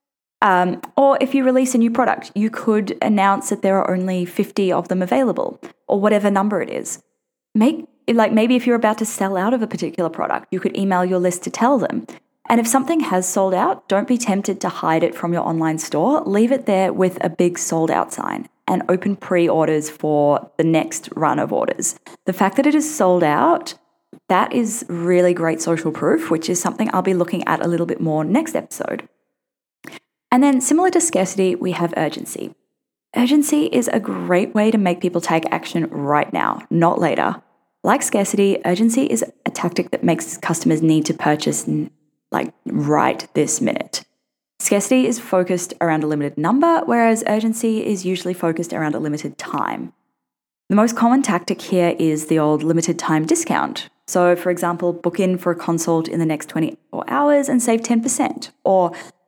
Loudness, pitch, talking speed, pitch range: -18 LUFS, 190 Hz, 190 wpm, 170-240 Hz